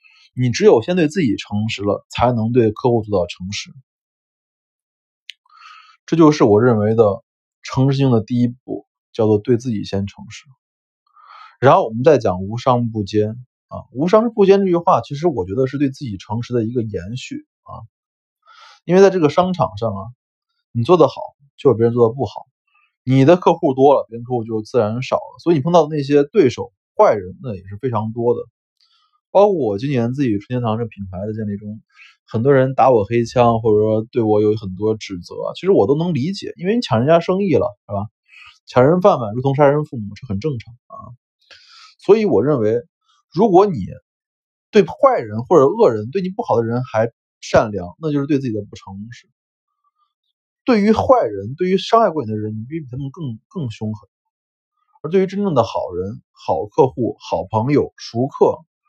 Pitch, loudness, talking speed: 130 Hz, -17 LUFS, 275 characters per minute